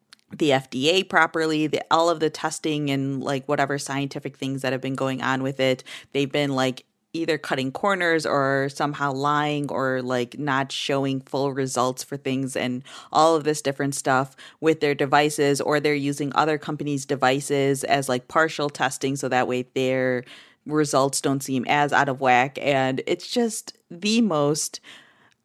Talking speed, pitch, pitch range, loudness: 170 wpm, 140 Hz, 130-150 Hz, -23 LUFS